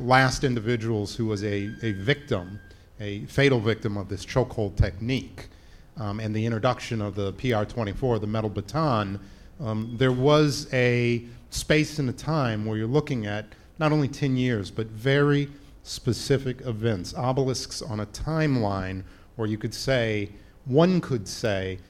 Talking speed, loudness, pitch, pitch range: 150 wpm, -26 LUFS, 115 Hz, 105-130 Hz